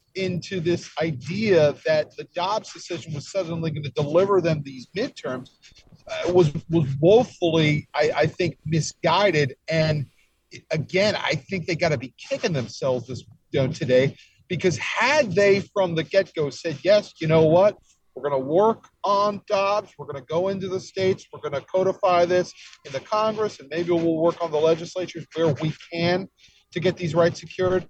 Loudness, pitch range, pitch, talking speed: -23 LUFS, 150-185 Hz, 170 Hz, 180 wpm